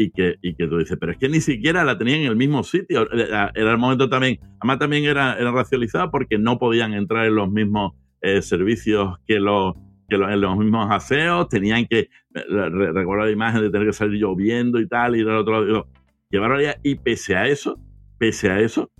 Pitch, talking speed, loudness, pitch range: 110 Hz, 215 wpm, -20 LUFS, 100-120 Hz